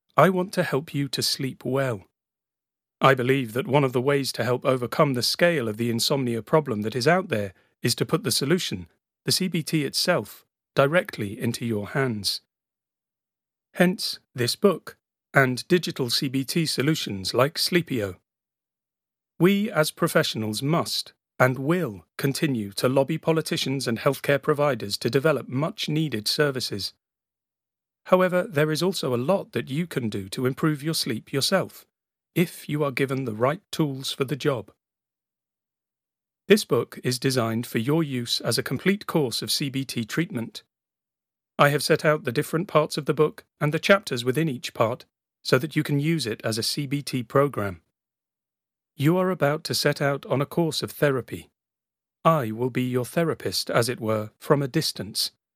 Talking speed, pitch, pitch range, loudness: 165 wpm, 135 Hz, 120-160 Hz, -24 LUFS